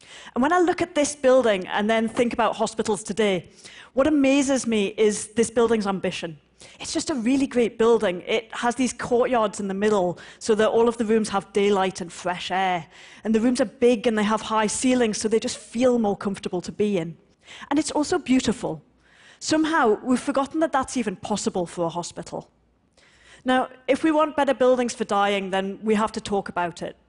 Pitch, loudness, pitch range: 225 Hz, -23 LUFS, 200-255 Hz